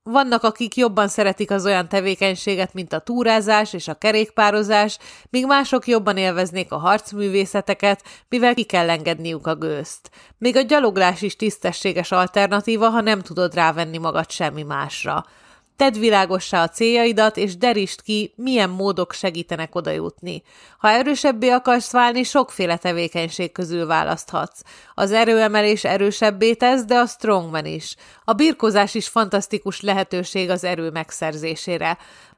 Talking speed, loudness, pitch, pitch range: 135 wpm, -19 LUFS, 200 Hz, 180-225 Hz